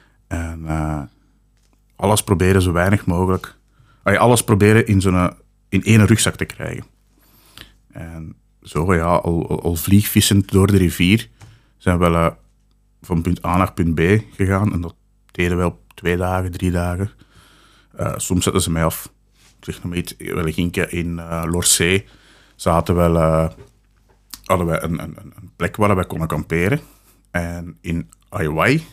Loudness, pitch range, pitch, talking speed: -18 LUFS, 85-105 Hz, 90 Hz, 155 wpm